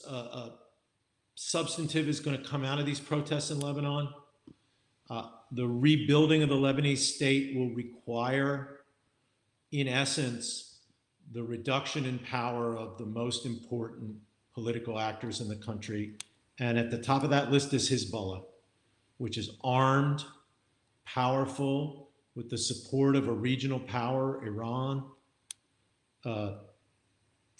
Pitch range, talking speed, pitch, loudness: 115-140 Hz, 130 wpm, 125 Hz, -32 LUFS